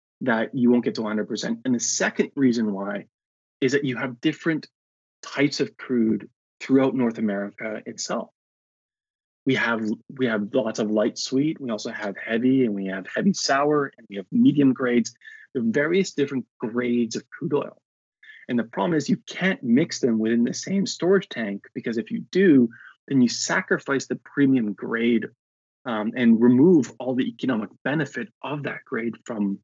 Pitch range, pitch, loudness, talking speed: 110-145 Hz, 125 Hz, -24 LUFS, 175 wpm